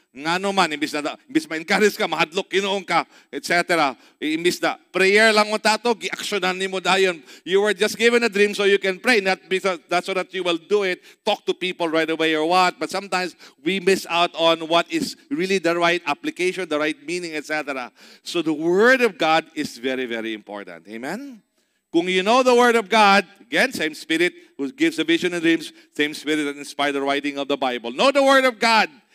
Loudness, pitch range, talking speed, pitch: -20 LUFS, 160-215 Hz, 185 wpm, 185 Hz